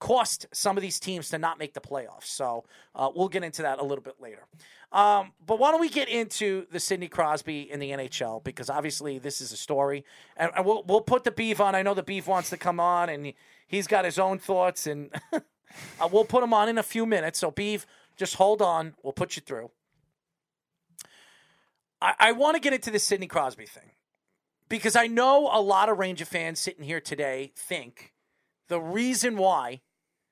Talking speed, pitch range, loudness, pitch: 205 wpm, 150-210 Hz, -27 LUFS, 180 Hz